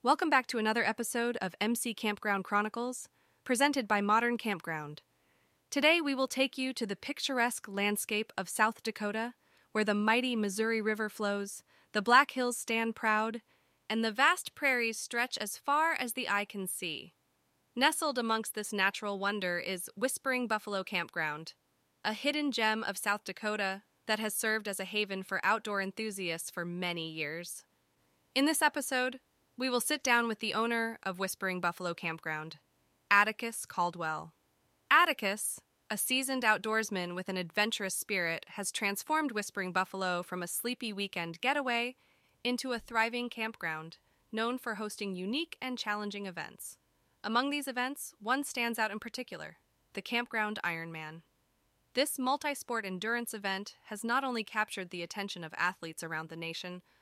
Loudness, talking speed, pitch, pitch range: -32 LUFS, 155 wpm, 215 Hz, 190-245 Hz